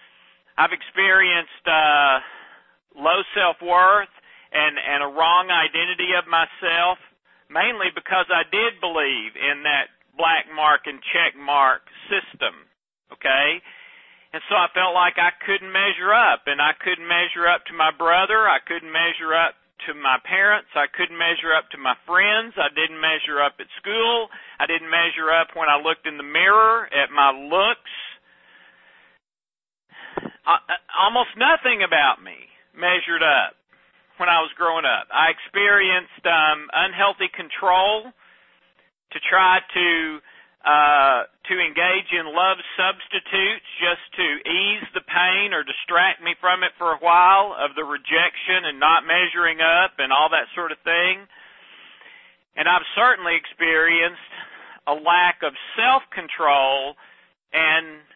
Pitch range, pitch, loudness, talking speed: 160-190 Hz, 170 Hz, -19 LUFS, 145 wpm